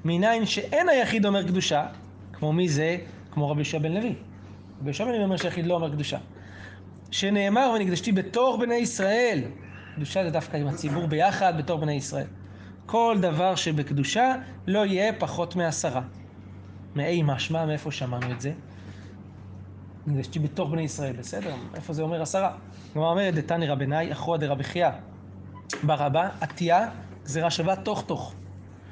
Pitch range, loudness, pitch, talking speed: 120-185 Hz, -26 LUFS, 155 Hz, 145 wpm